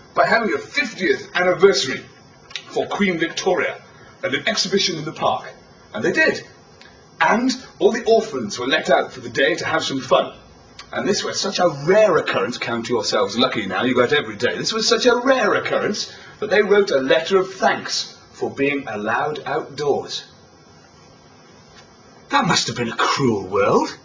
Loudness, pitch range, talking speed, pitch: -19 LUFS, 155-220 Hz, 175 wpm, 185 Hz